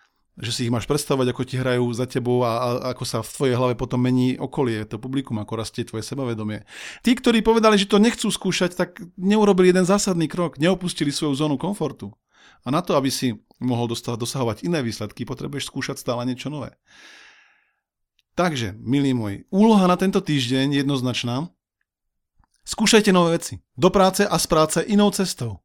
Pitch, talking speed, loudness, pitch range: 140 Hz, 175 wpm, -21 LUFS, 125-180 Hz